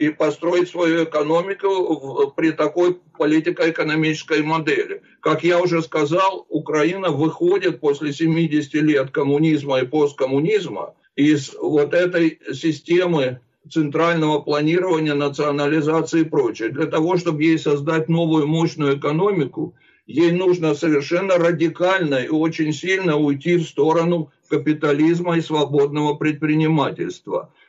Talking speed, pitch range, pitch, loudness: 110 wpm, 150-170 Hz, 160 Hz, -19 LUFS